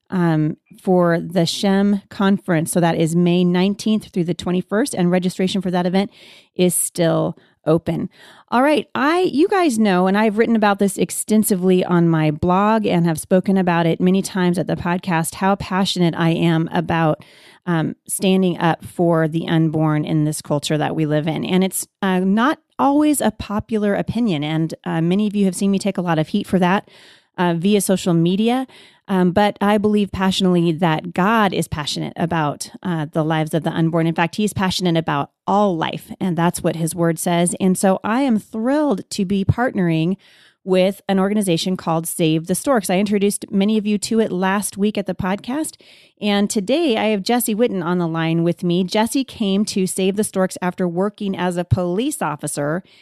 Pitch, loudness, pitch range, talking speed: 185 Hz, -19 LUFS, 170-205 Hz, 195 wpm